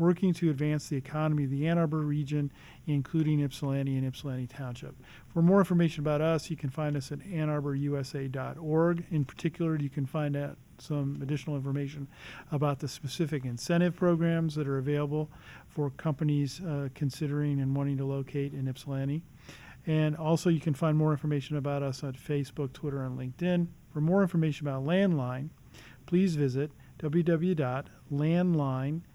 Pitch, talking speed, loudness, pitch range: 145 Hz, 155 wpm, -31 LUFS, 140-160 Hz